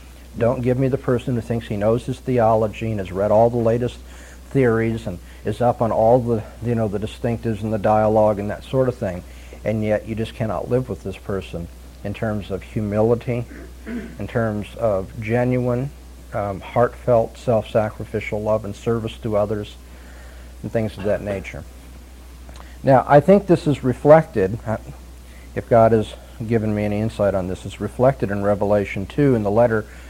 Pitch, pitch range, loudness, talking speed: 110 Hz, 95-120 Hz, -20 LUFS, 175 wpm